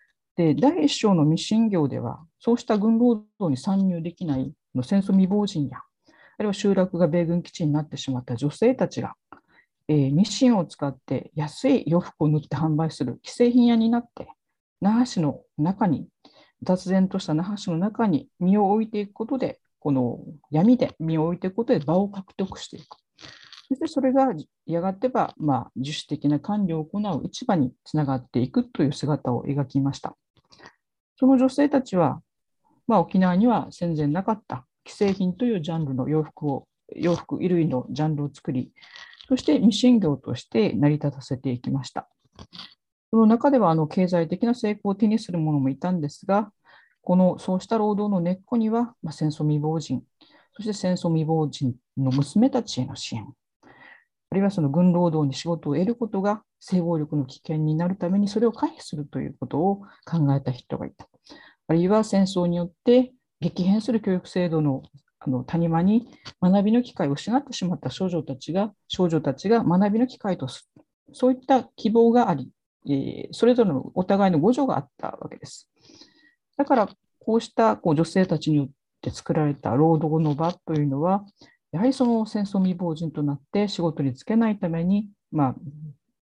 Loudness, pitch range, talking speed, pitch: -24 LUFS, 150-225 Hz, 335 characters per minute, 180 Hz